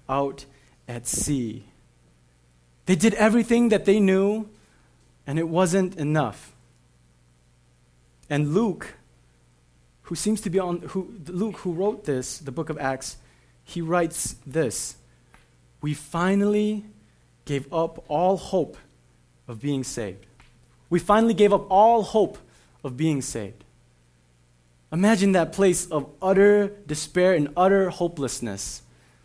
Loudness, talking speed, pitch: -23 LUFS, 120 wpm, 145 Hz